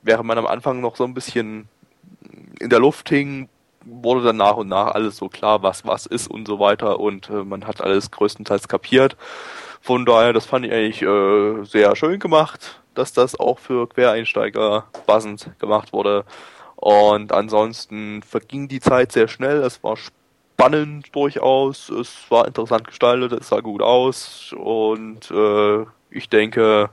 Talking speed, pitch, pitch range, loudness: 165 wpm, 110 Hz, 105-125 Hz, -18 LUFS